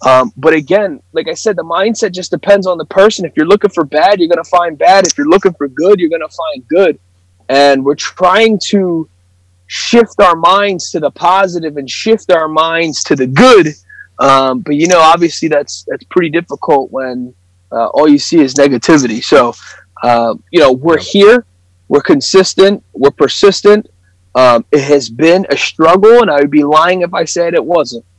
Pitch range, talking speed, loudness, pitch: 135-190 Hz, 190 wpm, -9 LUFS, 160 Hz